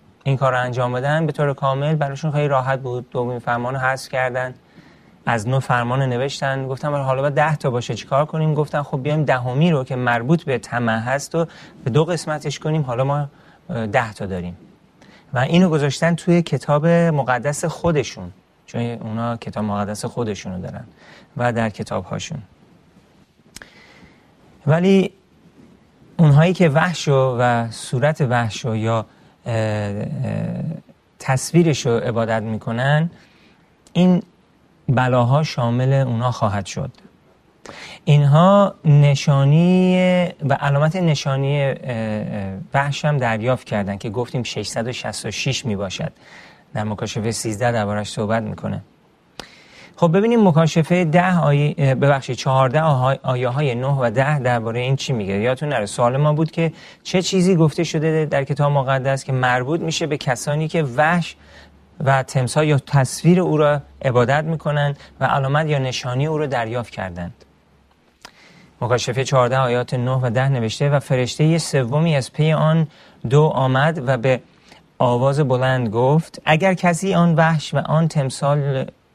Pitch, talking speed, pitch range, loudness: 135 Hz, 140 wpm, 125-155 Hz, -19 LUFS